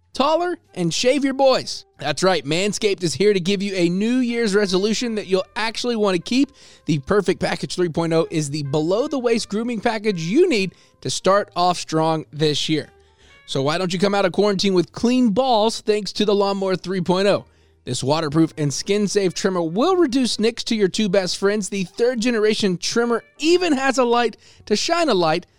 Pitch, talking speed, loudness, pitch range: 200 Hz, 195 wpm, -20 LUFS, 170-230 Hz